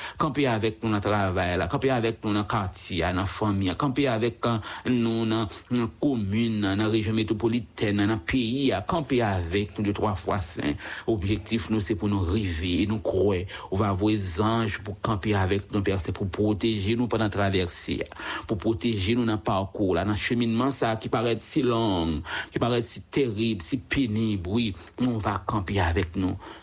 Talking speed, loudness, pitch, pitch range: 195 wpm, -26 LUFS, 110 Hz, 100-115 Hz